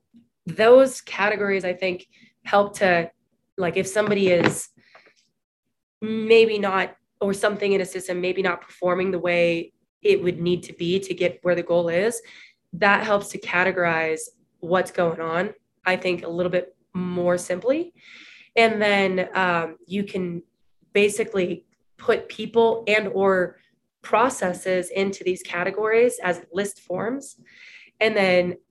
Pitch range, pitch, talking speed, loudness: 180-210 Hz, 185 Hz, 140 wpm, -22 LUFS